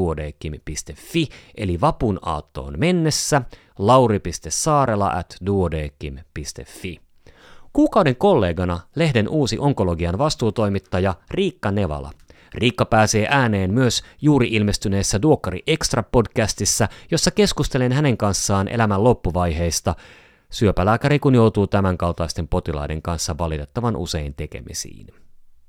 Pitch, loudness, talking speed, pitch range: 100 Hz, -20 LUFS, 85 wpm, 85-125 Hz